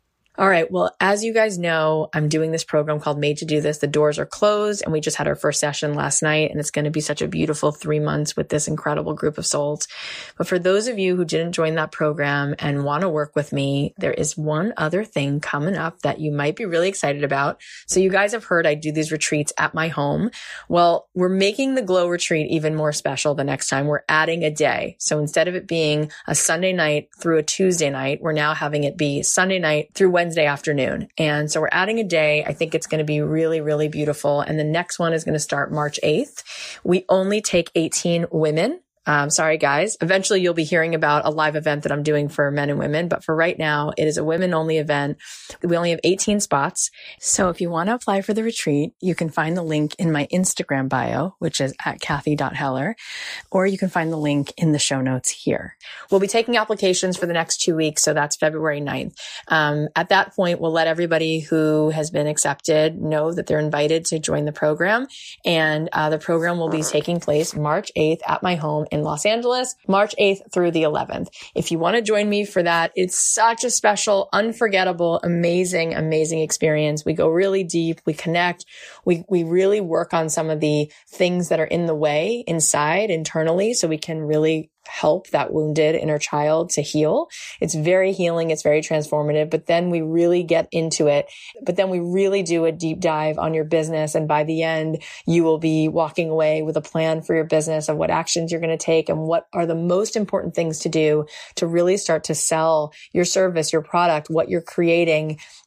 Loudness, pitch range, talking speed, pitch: -20 LUFS, 150-180 Hz, 220 wpm, 160 Hz